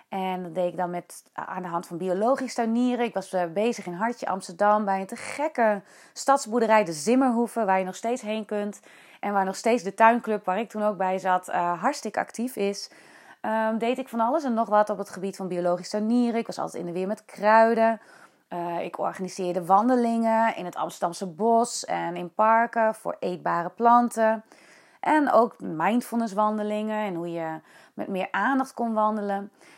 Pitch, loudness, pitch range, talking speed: 215 Hz, -25 LUFS, 185-230 Hz, 190 wpm